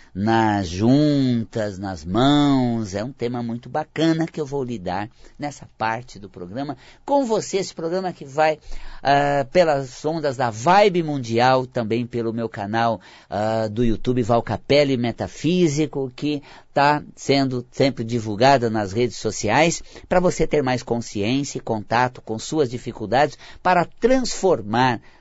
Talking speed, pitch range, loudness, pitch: 140 wpm, 115-150 Hz, -21 LUFS, 130 Hz